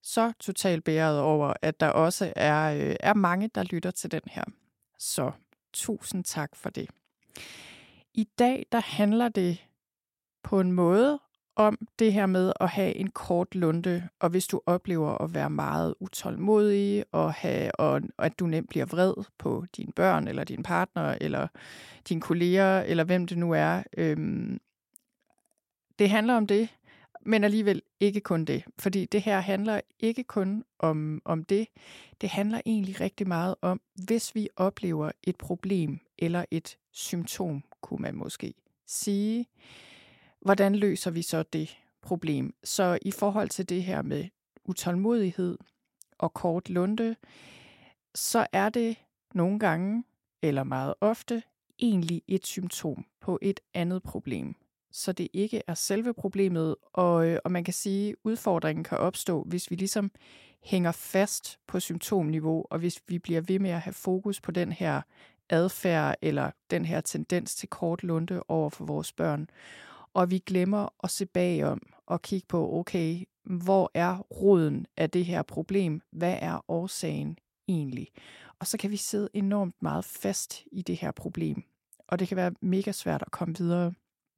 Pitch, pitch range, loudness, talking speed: 185 Hz, 170-205 Hz, -29 LUFS, 160 wpm